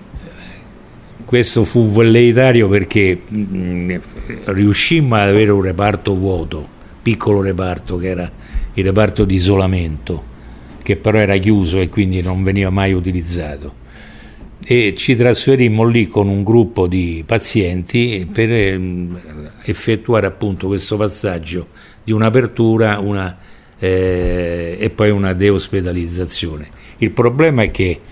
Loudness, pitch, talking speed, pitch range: -15 LUFS, 100 Hz, 120 wpm, 90-110 Hz